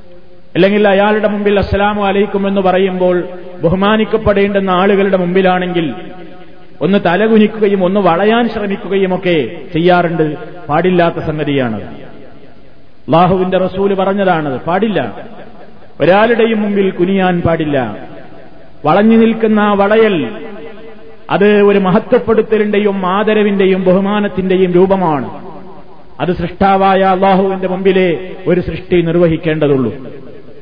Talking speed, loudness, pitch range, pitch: 85 wpm, -12 LUFS, 180-205 Hz, 190 Hz